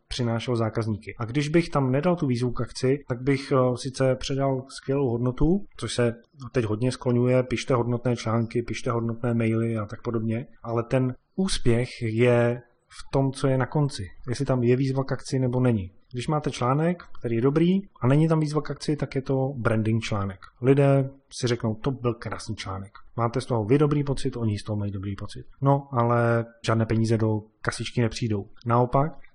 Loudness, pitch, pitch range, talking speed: -25 LUFS, 125 Hz, 115-135 Hz, 190 wpm